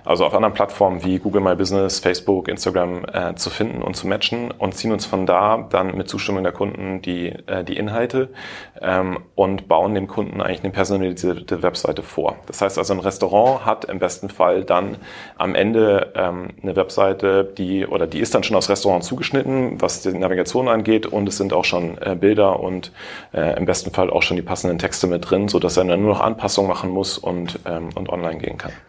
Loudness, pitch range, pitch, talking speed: -20 LUFS, 90-100 Hz, 95 Hz, 210 wpm